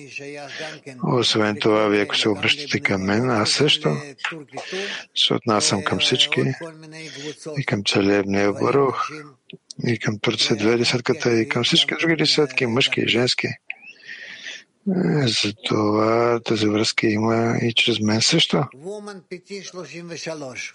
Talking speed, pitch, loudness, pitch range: 115 wpm, 125 Hz, -20 LUFS, 110-155 Hz